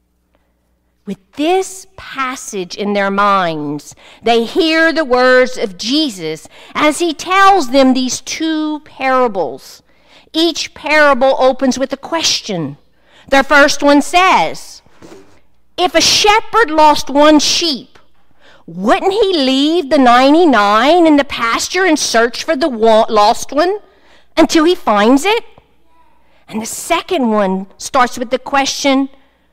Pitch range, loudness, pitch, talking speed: 230-325 Hz, -12 LUFS, 275 Hz, 125 wpm